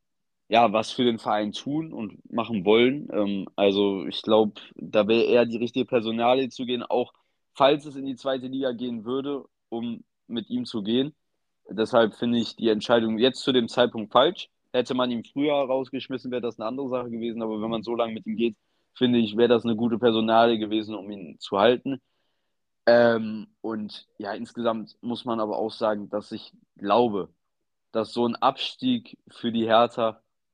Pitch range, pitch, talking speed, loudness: 110-125 Hz, 115 Hz, 185 wpm, -25 LUFS